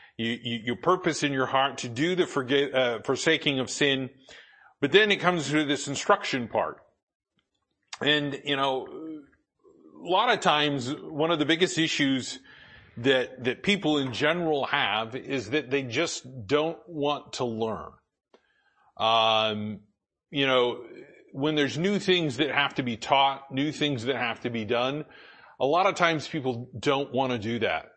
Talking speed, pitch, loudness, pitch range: 165 wpm, 140 Hz, -26 LUFS, 125-150 Hz